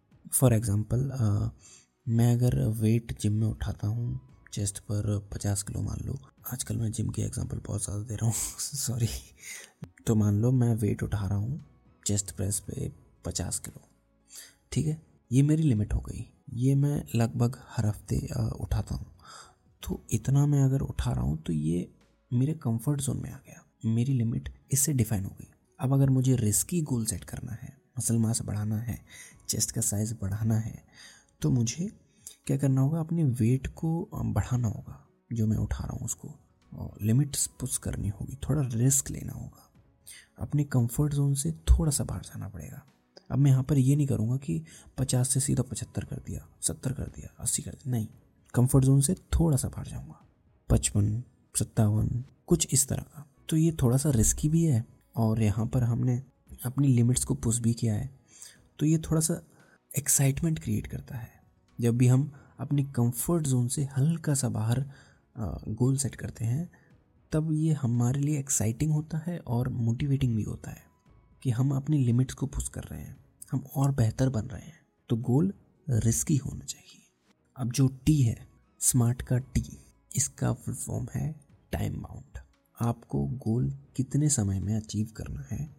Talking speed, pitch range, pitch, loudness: 175 wpm, 110-140 Hz, 125 Hz, -29 LUFS